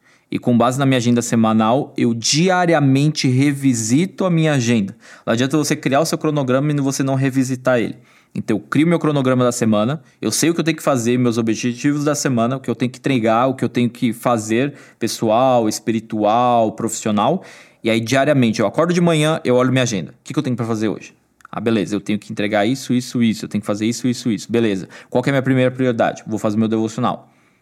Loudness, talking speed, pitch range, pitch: -18 LUFS, 230 wpm, 115-140 Hz, 125 Hz